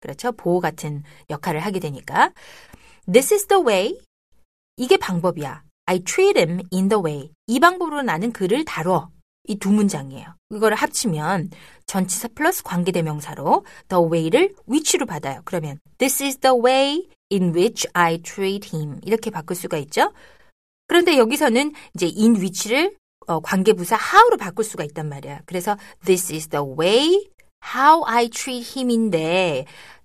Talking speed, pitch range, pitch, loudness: 410 characters per minute, 165-255 Hz, 195 Hz, -20 LUFS